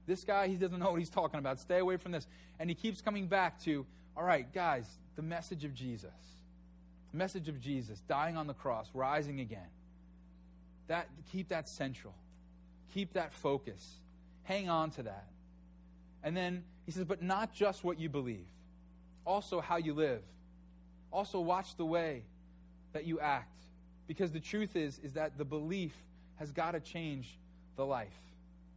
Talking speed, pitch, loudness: 170 wpm, 140 Hz, -38 LUFS